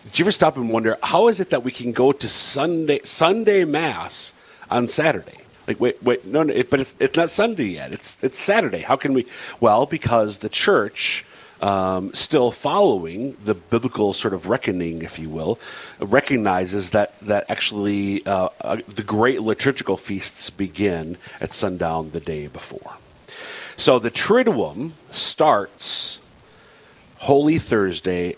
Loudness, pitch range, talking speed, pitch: -20 LUFS, 95-140 Hz, 155 wpm, 110 Hz